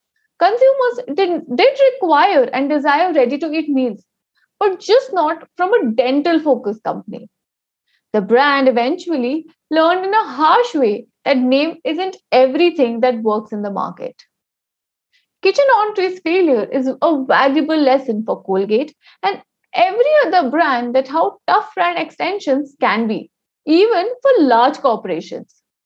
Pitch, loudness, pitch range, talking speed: 310 Hz, -16 LUFS, 260-370 Hz, 130 wpm